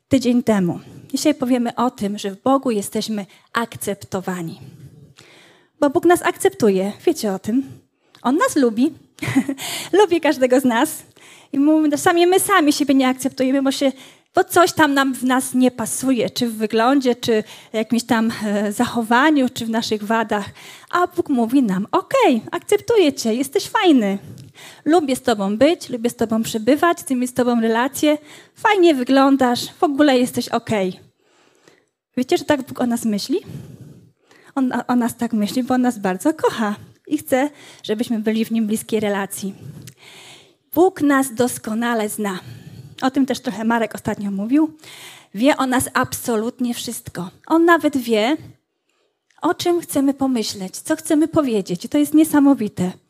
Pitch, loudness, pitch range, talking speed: 250 Hz, -19 LUFS, 220-300 Hz, 155 wpm